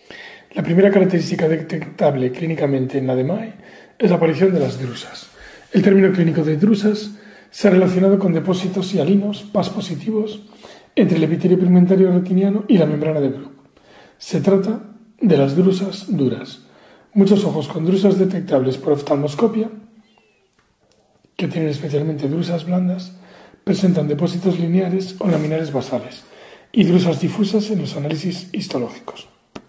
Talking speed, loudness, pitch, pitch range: 135 wpm, -18 LUFS, 185 Hz, 160-200 Hz